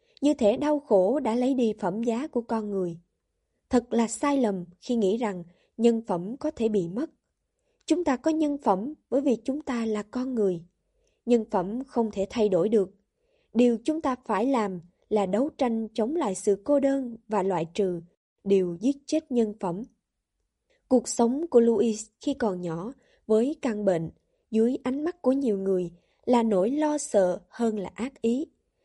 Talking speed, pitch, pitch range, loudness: 185 wpm, 230 Hz, 200-270 Hz, -26 LUFS